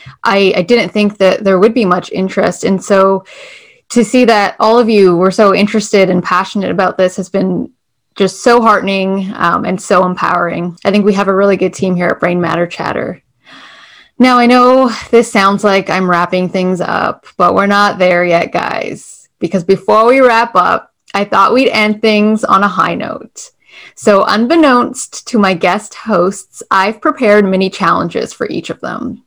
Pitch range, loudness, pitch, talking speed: 185-220 Hz, -11 LUFS, 195 Hz, 185 wpm